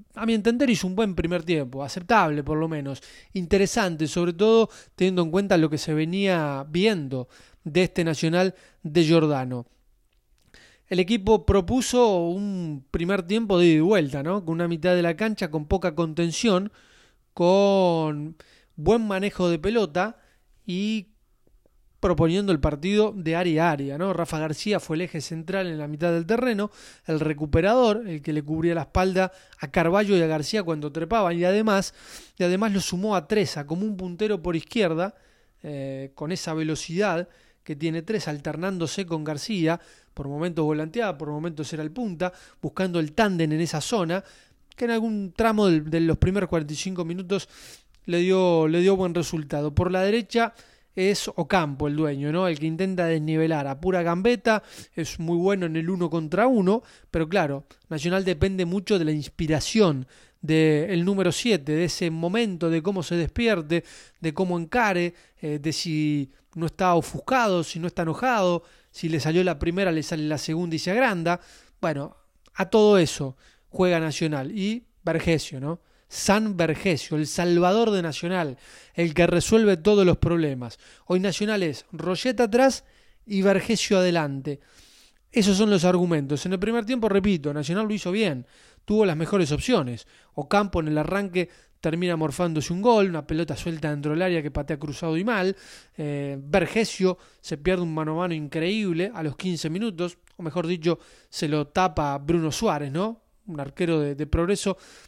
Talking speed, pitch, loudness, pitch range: 170 wpm, 175 Hz, -24 LUFS, 160-195 Hz